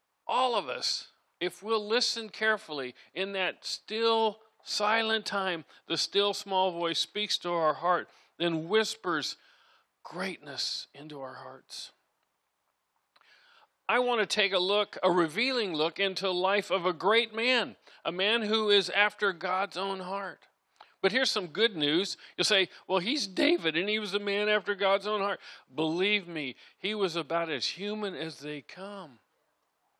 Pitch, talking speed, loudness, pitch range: 195 Hz, 160 wpm, -29 LUFS, 175-215 Hz